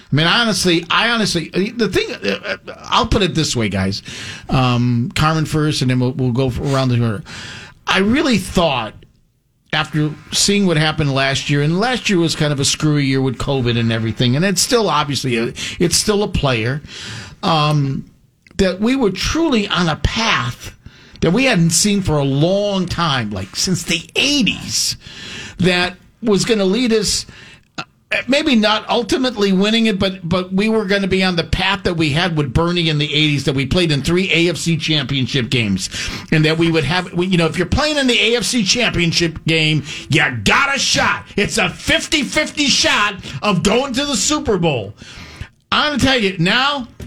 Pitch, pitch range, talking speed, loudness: 170 Hz, 140-205 Hz, 190 wpm, -16 LUFS